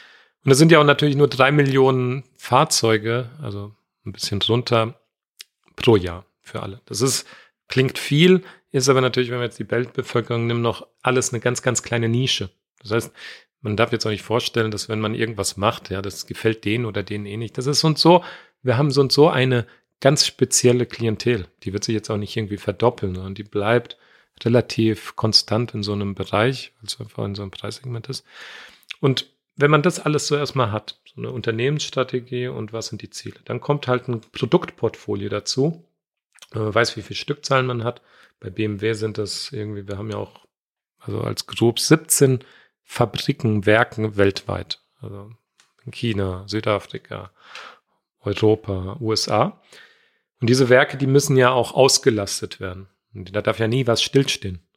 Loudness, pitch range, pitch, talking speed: -20 LUFS, 105-130 Hz, 115 Hz, 180 wpm